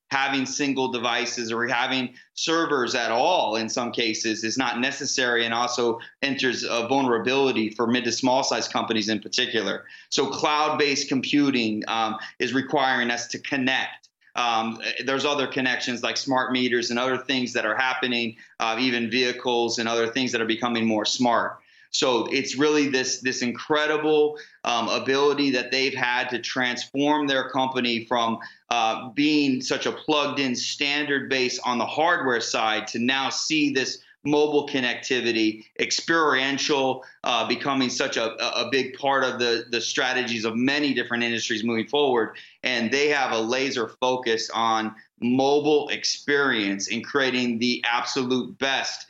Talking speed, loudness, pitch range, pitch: 155 wpm, -23 LUFS, 115-135 Hz, 125 Hz